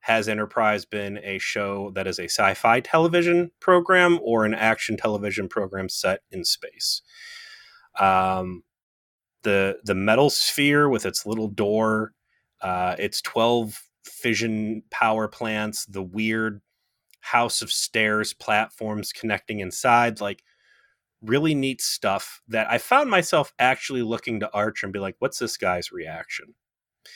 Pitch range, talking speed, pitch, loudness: 100-120 Hz, 135 wpm, 110 Hz, -23 LUFS